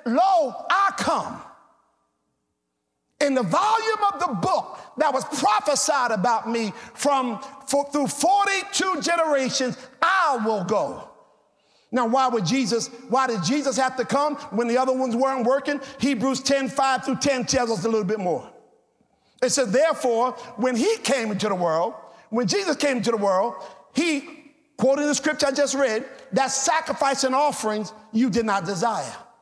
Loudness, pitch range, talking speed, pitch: -23 LUFS, 235-290 Hz, 160 wpm, 265 Hz